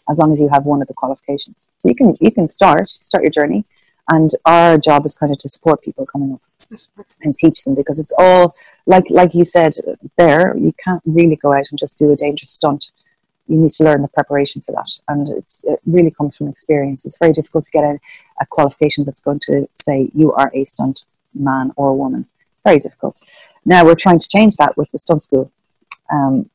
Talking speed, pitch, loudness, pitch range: 220 wpm, 150 Hz, -14 LUFS, 140-170 Hz